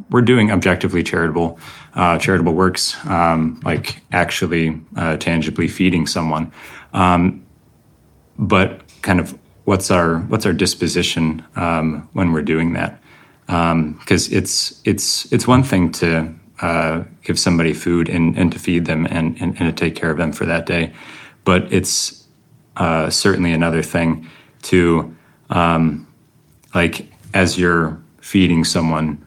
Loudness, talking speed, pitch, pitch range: -17 LUFS, 140 wpm, 85 Hz, 80-90 Hz